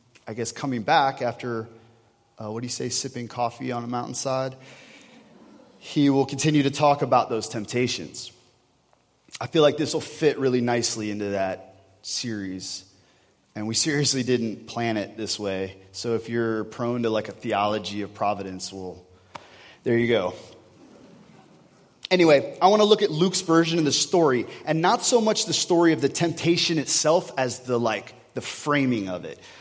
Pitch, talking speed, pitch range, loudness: 120 Hz, 170 wpm, 110-150 Hz, -24 LUFS